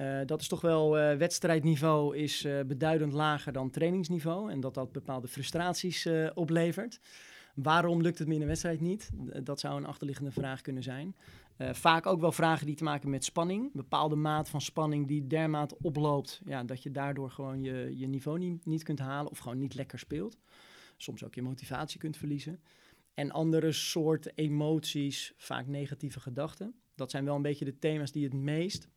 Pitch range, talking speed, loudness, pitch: 140-165 Hz, 190 wpm, -33 LUFS, 150 Hz